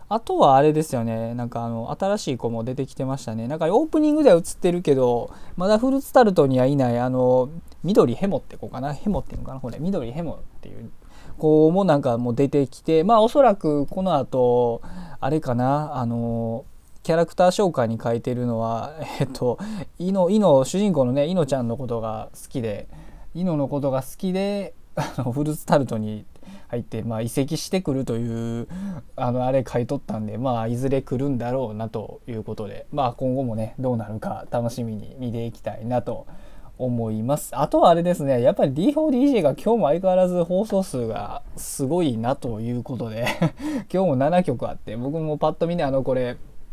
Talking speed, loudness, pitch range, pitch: 385 characters per minute, -22 LUFS, 120-170 Hz, 135 Hz